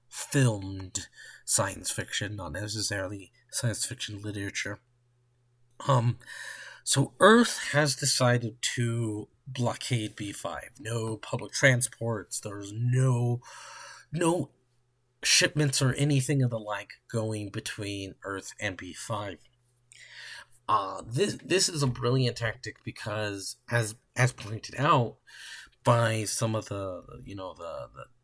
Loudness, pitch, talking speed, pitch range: -28 LUFS, 120 Hz, 115 wpm, 105-130 Hz